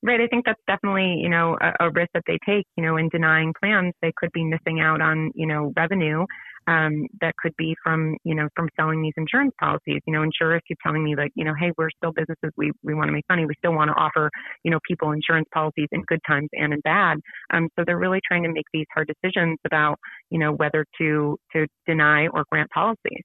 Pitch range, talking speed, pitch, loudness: 155-170 Hz, 245 wpm, 160 Hz, -22 LUFS